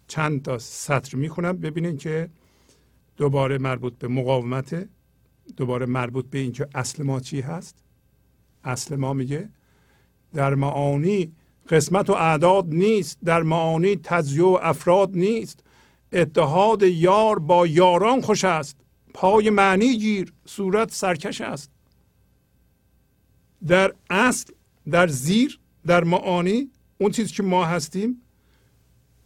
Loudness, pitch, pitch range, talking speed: -22 LUFS, 170 Hz, 140-195 Hz, 115 wpm